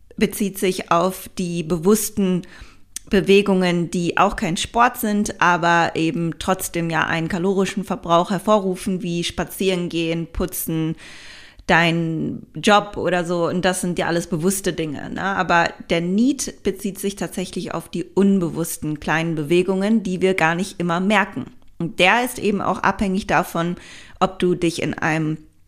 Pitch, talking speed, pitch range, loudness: 185 Hz, 150 wpm, 170-195 Hz, -20 LUFS